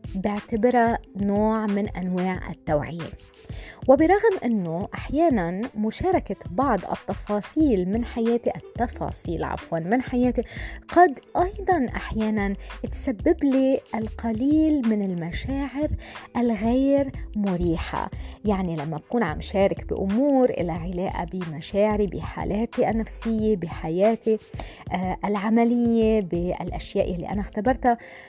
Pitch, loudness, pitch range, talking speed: 220 Hz, -24 LUFS, 185-250 Hz, 95 wpm